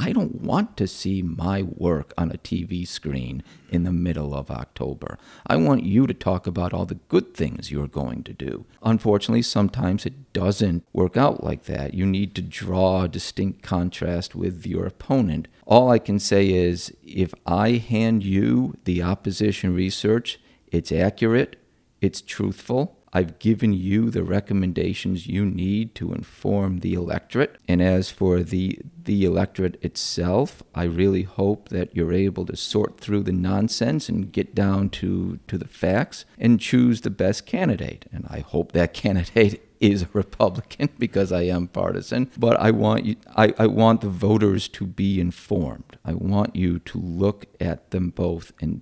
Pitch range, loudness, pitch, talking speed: 90-105 Hz, -23 LUFS, 95 Hz, 170 wpm